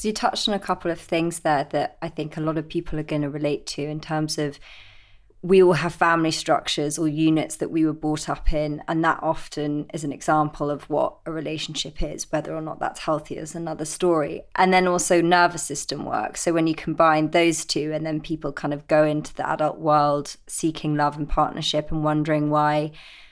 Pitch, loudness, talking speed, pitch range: 155 Hz, -23 LUFS, 220 wpm, 150-165 Hz